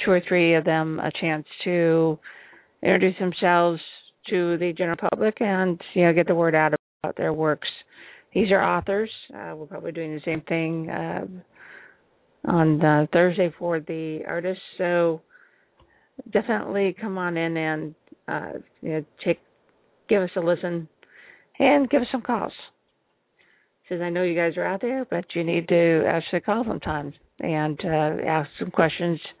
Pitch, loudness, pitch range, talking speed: 170 Hz, -24 LUFS, 160-190 Hz, 165 wpm